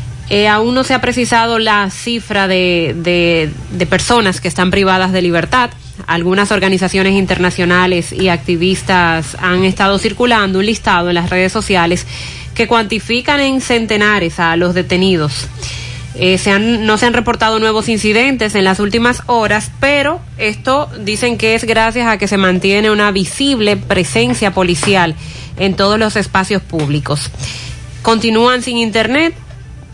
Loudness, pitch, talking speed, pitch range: -12 LUFS, 195 Hz, 145 wpm, 180-225 Hz